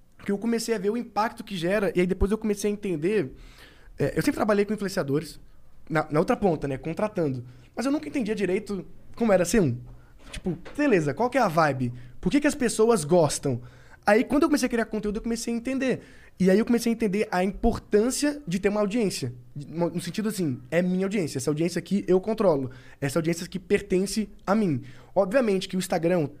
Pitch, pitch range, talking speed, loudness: 195 Hz, 160-220 Hz, 215 wpm, -26 LUFS